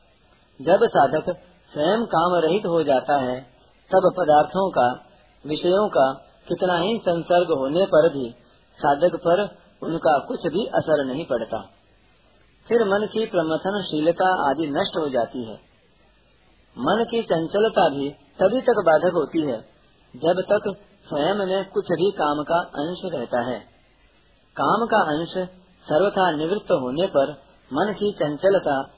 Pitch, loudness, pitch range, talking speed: 175 Hz, -22 LUFS, 145-195 Hz, 135 wpm